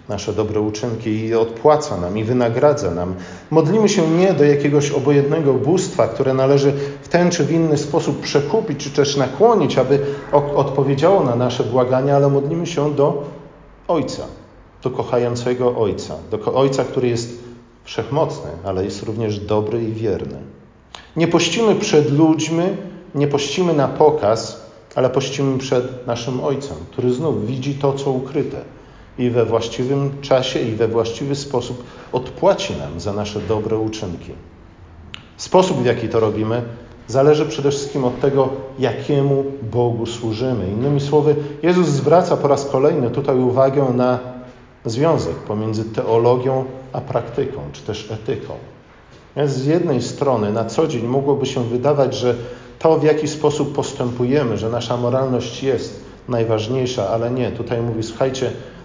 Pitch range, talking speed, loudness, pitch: 115-145 Hz, 145 wpm, -18 LUFS, 130 Hz